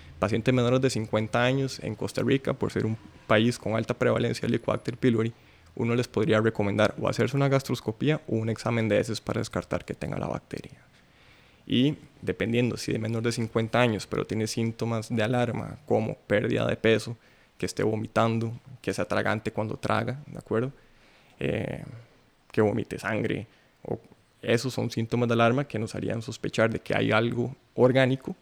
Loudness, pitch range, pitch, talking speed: -27 LUFS, 110-125 Hz, 115 Hz, 175 wpm